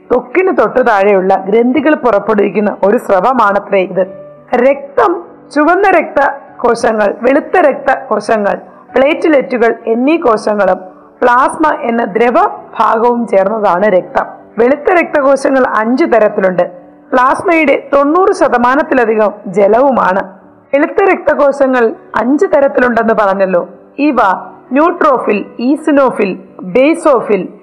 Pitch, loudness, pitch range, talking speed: 250 Hz, -11 LUFS, 215-295 Hz, 90 wpm